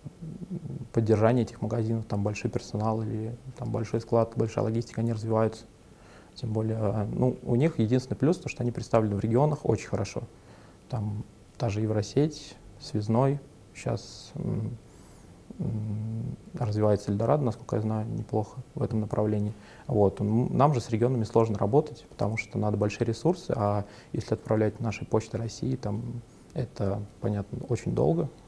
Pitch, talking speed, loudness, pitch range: 115 Hz, 145 wpm, -29 LUFS, 105-125 Hz